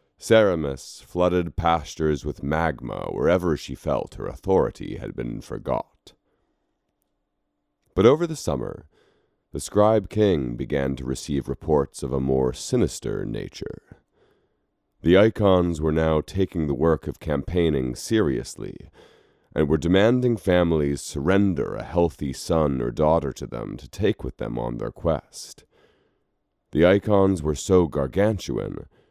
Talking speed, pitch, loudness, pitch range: 130 wpm, 80 Hz, -23 LUFS, 70-95 Hz